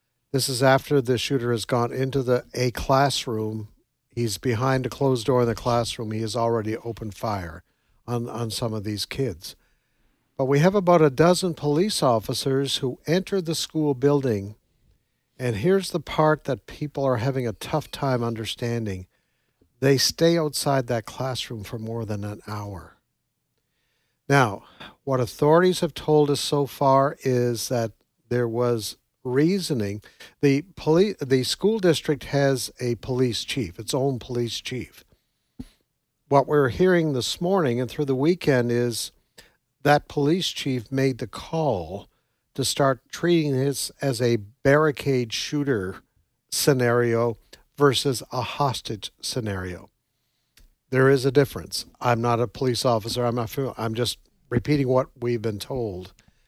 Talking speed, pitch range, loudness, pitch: 150 wpm, 115-140 Hz, -24 LUFS, 130 Hz